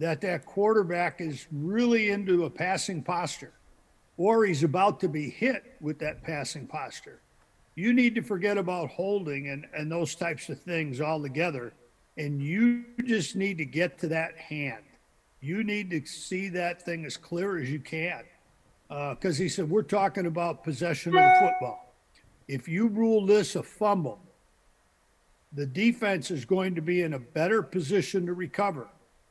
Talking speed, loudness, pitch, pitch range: 170 wpm, -28 LUFS, 175 Hz, 150-195 Hz